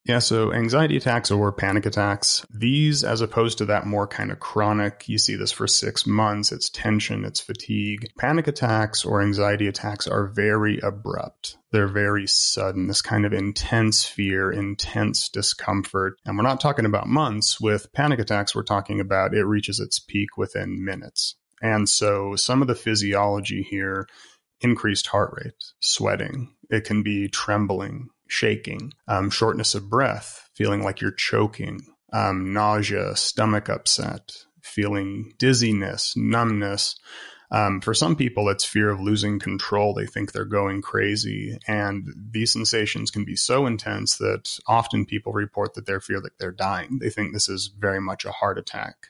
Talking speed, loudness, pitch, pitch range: 165 wpm, -23 LUFS, 105 Hz, 100-115 Hz